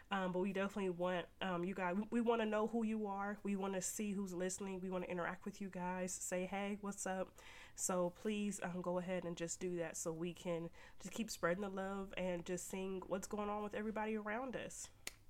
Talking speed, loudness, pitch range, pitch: 235 wpm, -43 LUFS, 180-205 Hz, 190 Hz